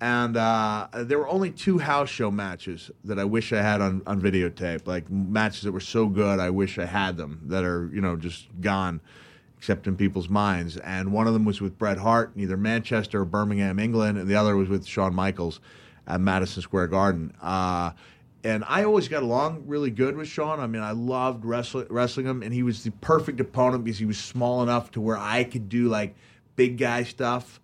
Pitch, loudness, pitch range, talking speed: 105 Hz, -26 LUFS, 95-120 Hz, 215 wpm